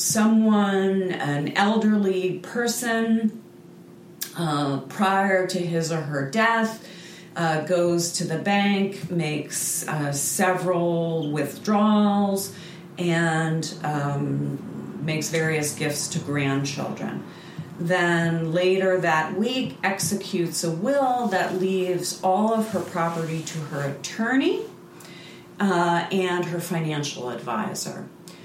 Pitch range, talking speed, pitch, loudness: 160-195 Hz, 100 wpm, 175 Hz, -24 LUFS